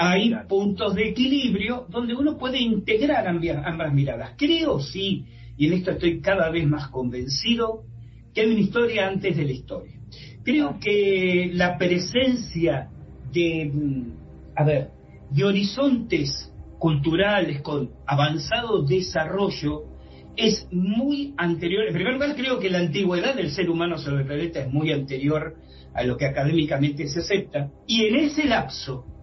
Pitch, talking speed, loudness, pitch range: 170 Hz, 145 wpm, -23 LUFS, 140-210 Hz